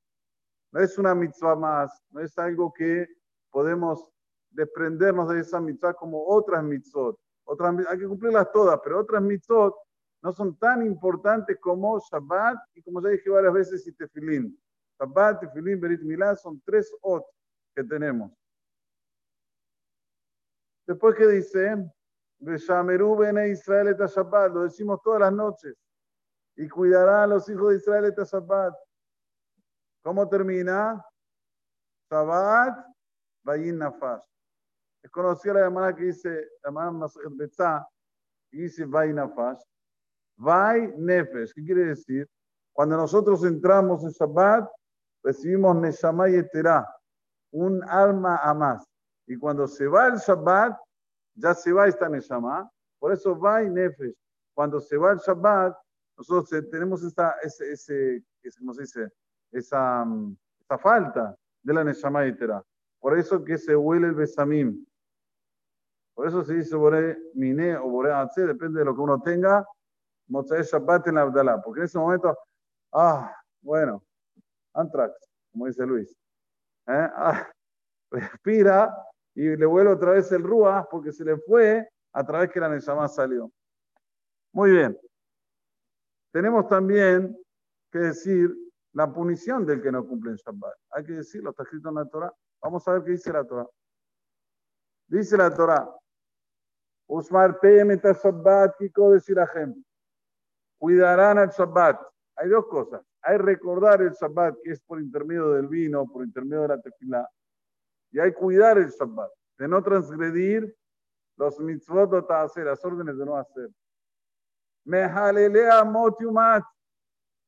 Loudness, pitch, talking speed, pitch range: -23 LUFS, 175 Hz, 135 wpm, 150-200 Hz